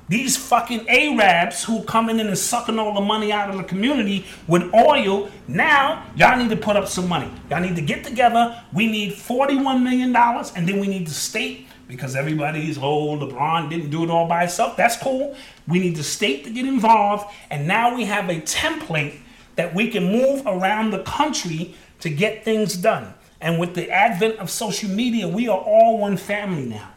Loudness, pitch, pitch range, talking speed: -20 LUFS, 205 Hz, 175-235 Hz, 205 wpm